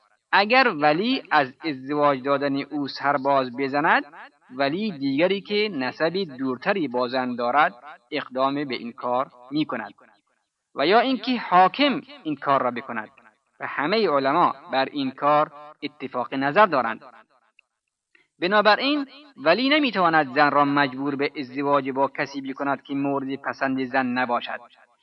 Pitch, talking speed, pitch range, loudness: 145 Hz, 130 wpm, 135-195 Hz, -23 LUFS